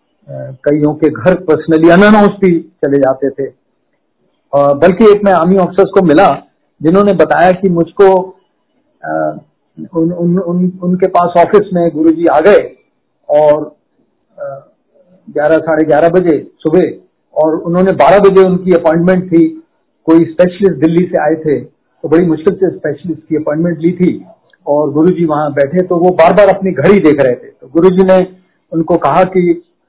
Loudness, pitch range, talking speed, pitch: -10 LUFS, 155-190 Hz, 155 wpm, 175 Hz